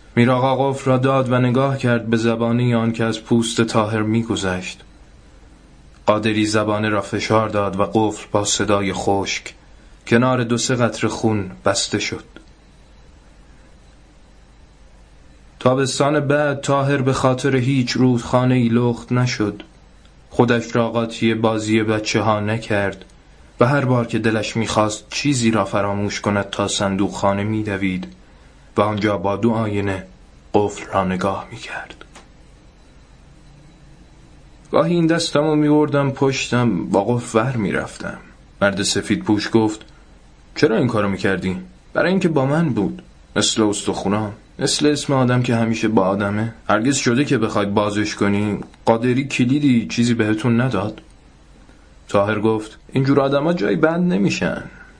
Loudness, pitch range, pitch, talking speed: -19 LUFS, 100-125 Hz, 110 Hz, 135 wpm